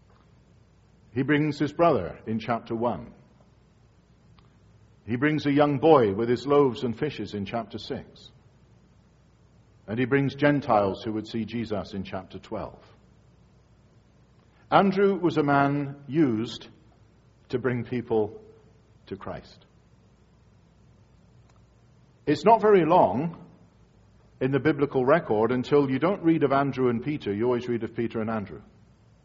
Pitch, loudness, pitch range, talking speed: 125 Hz, -25 LUFS, 110-145 Hz, 130 wpm